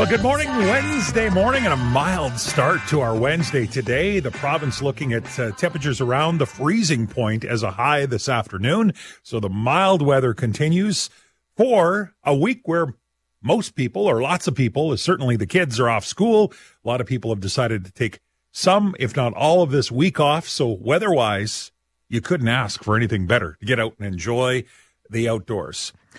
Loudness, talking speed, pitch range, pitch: -20 LUFS, 185 wpm, 115-165 Hz, 130 Hz